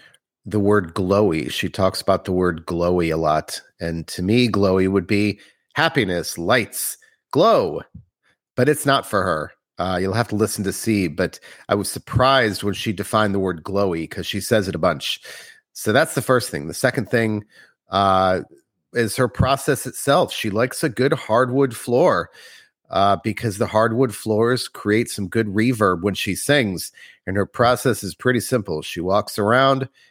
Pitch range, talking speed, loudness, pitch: 95-125 Hz, 175 wpm, -20 LUFS, 105 Hz